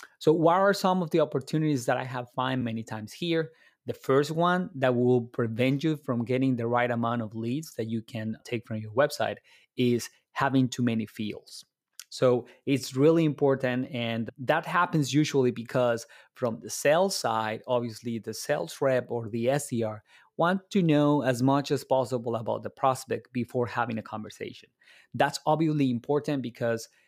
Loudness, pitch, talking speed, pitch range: -28 LUFS, 130 Hz, 175 wpm, 115-145 Hz